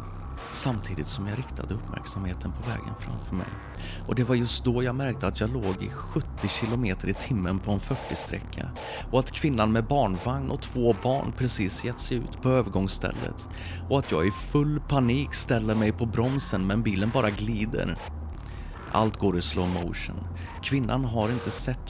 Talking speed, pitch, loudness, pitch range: 175 wpm, 105 Hz, -28 LUFS, 90-125 Hz